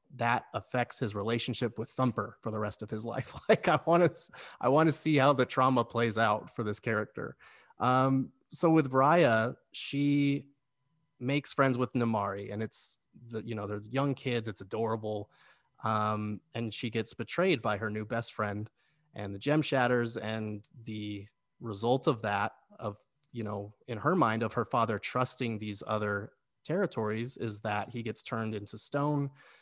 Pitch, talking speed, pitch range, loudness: 115 Hz, 170 wpm, 110-135 Hz, -31 LUFS